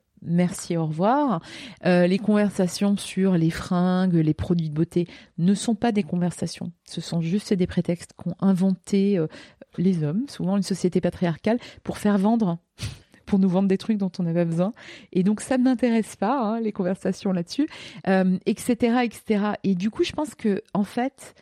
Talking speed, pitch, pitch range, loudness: 185 wpm, 190 Hz, 175-210 Hz, -24 LUFS